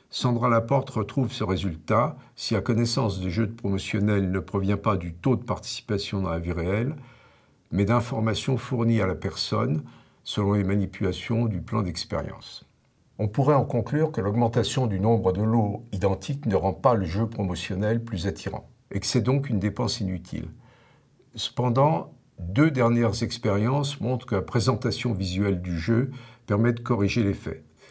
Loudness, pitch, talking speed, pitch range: -26 LUFS, 110 Hz, 165 wpm, 100-125 Hz